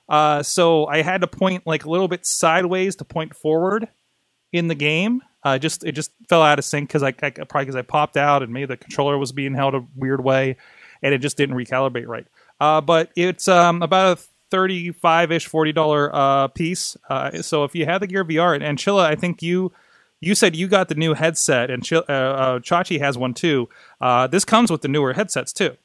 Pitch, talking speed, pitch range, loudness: 155 Hz, 225 wpm, 140-175 Hz, -19 LUFS